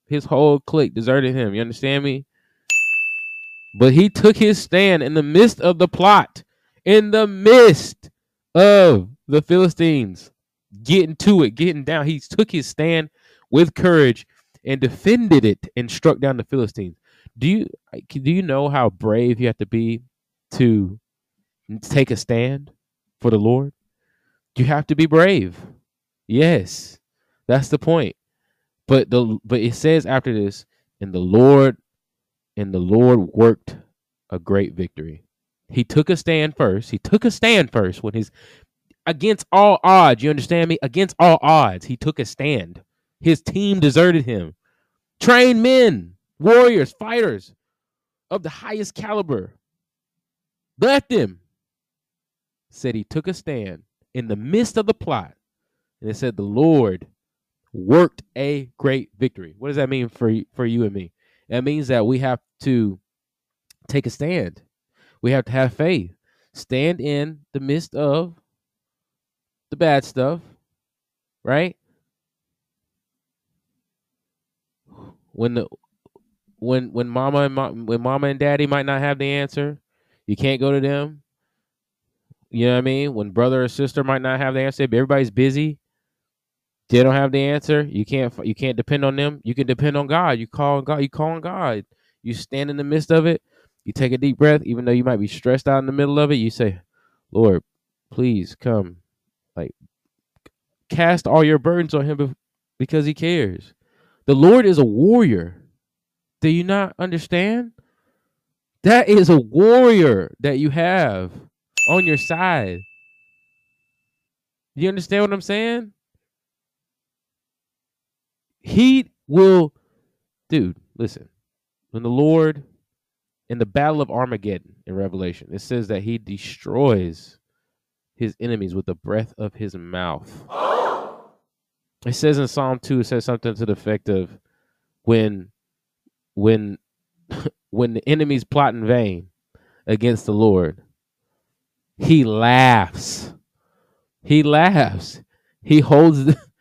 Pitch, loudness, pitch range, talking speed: 135 Hz, -17 LUFS, 115-160 Hz, 150 wpm